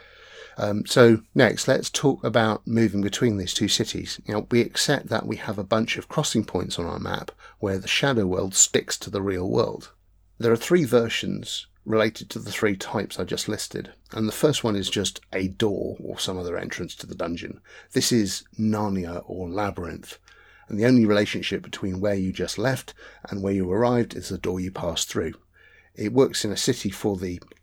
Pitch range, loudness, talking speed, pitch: 95-115 Hz, -24 LUFS, 200 wpm, 105 Hz